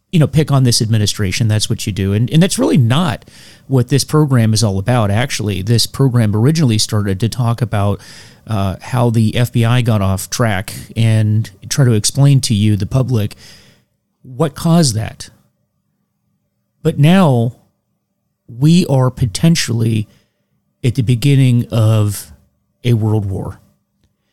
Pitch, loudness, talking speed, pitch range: 115 Hz, -14 LUFS, 145 wpm, 105-135 Hz